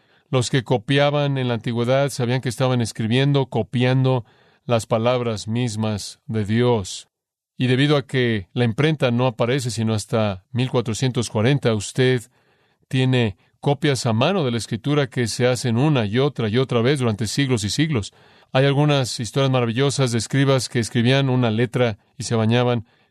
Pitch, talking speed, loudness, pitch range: 125 Hz, 160 wpm, -21 LUFS, 115-135 Hz